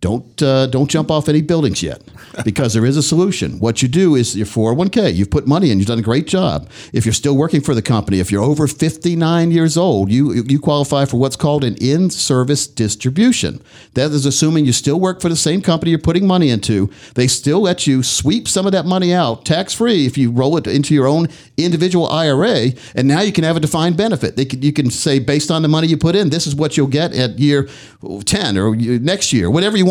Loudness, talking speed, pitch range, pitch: -15 LUFS, 240 wpm, 125-165 Hz, 145 Hz